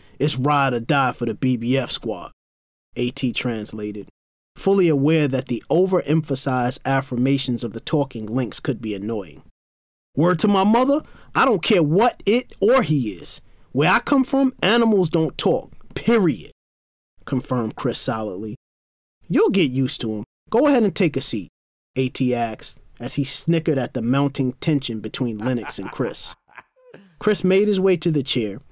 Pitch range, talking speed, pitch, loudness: 115-165 Hz, 160 wpm, 130 Hz, -20 LUFS